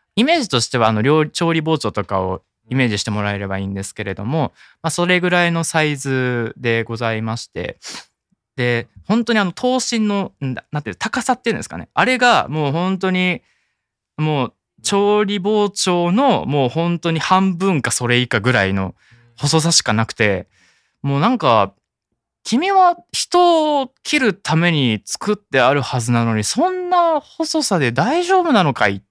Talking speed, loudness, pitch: 325 characters per minute, -17 LUFS, 160 Hz